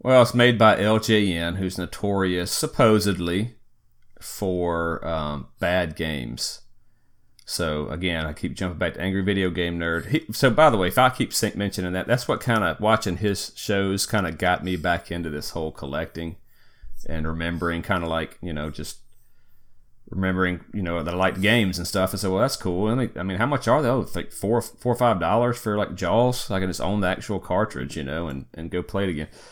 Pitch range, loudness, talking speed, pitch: 85-105 Hz, -23 LUFS, 215 wpm, 95 Hz